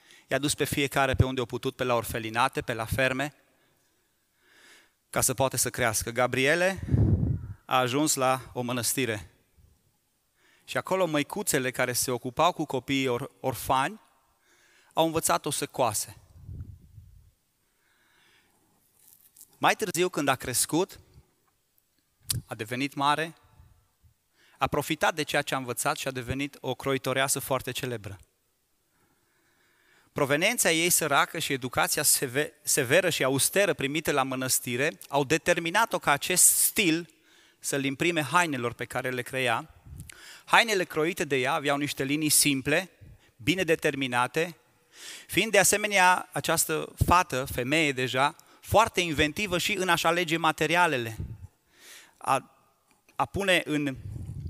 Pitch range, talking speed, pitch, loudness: 125-155 Hz, 120 wpm, 135 Hz, -26 LUFS